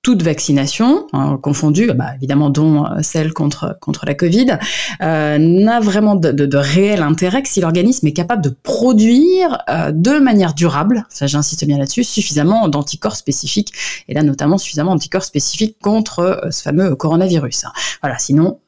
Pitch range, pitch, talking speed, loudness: 150-210 Hz, 165 Hz, 160 wpm, -14 LUFS